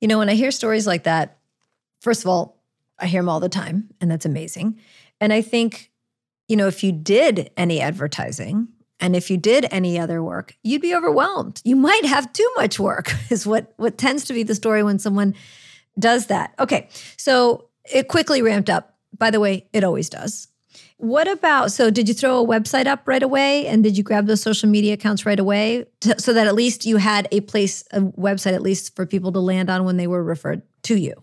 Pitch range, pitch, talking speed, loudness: 185-235 Hz, 210 Hz, 220 wpm, -19 LUFS